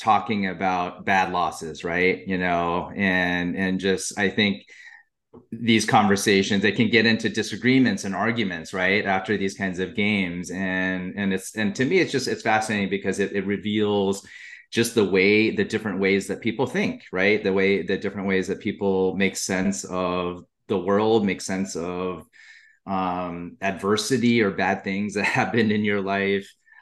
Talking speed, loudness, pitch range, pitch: 170 wpm, -23 LUFS, 95-105 Hz, 100 Hz